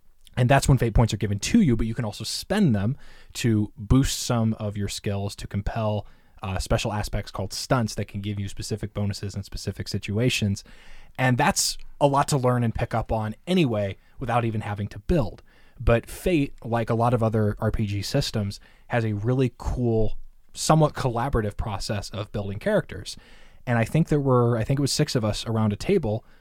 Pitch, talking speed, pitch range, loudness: 110 Hz, 200 wpm, 105-125 Hz, -25 LUFS